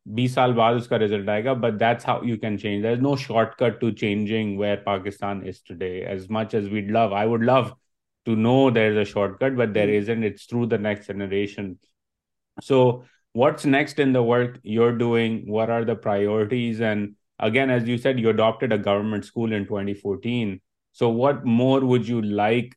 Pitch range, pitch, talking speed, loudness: 105-120 Hz, 115 Hz, 175 wpm, -22 LUFS